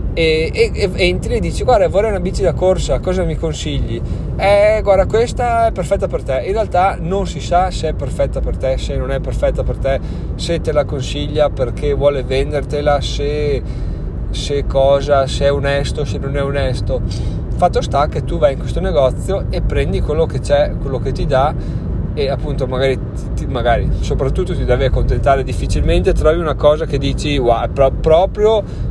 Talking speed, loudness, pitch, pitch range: 185 wpm, -16 LUFS, 140 Hz, 130-160 Hz